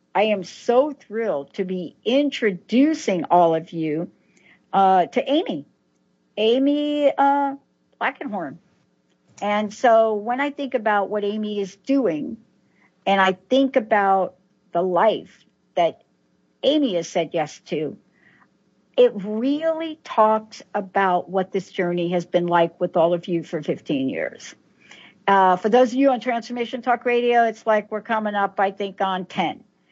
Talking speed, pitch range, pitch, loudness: 145 wpm, 185-255 Hz, 210 Hz, -21 LUFS